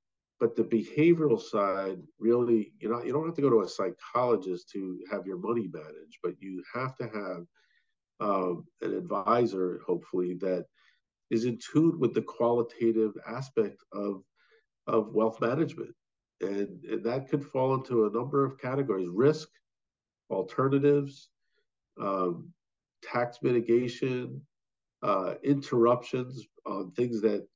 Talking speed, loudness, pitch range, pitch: 135 wpm, -30 LUFS, 100-130 Hz, 115 Hz